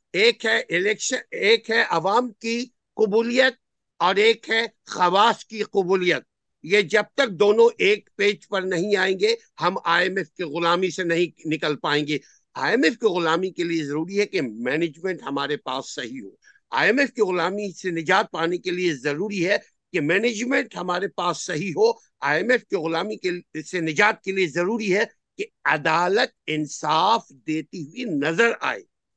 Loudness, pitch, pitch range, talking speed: -22 LUFS, 190 Hz, 170-230 Hz, 175 wpm